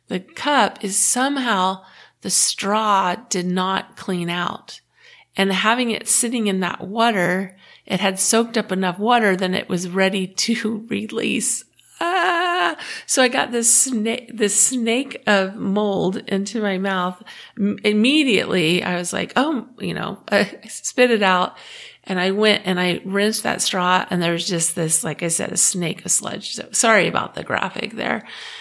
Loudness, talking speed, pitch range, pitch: -19 LUFS, 165 wpm, 185-235 Hz, 200 Hz